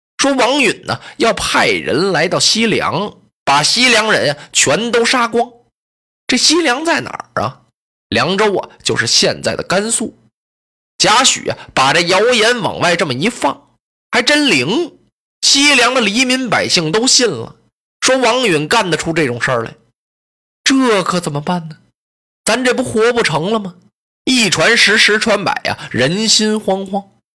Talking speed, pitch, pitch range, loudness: 220 characters per minute, 225 Hz, 190-255 Hz, -13 LUFS